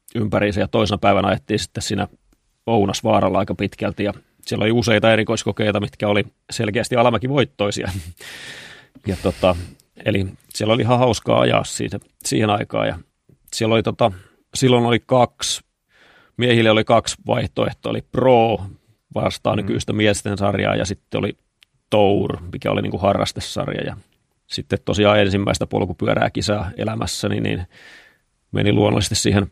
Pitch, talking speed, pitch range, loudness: 105 Hz, 135 wpm, 100-115 Hz, -19 LUFS